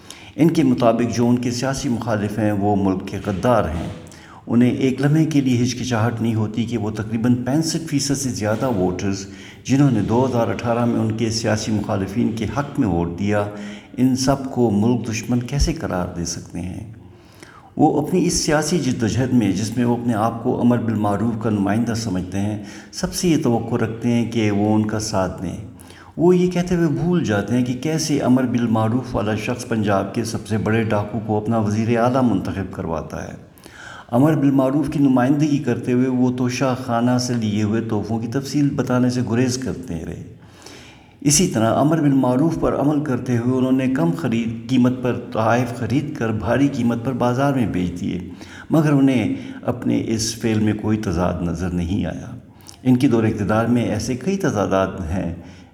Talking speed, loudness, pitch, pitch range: 190 wpm, -20 LUFS, 115 Hz, 105-130 Hz